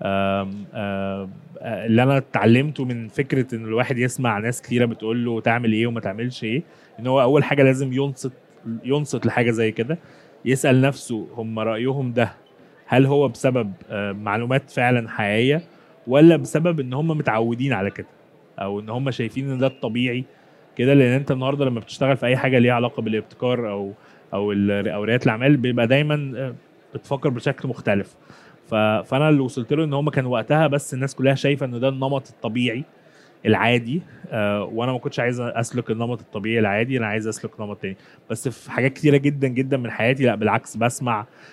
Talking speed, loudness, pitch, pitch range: 170 wpm, -21 LUFS, 125 Hz, 115-135 Hz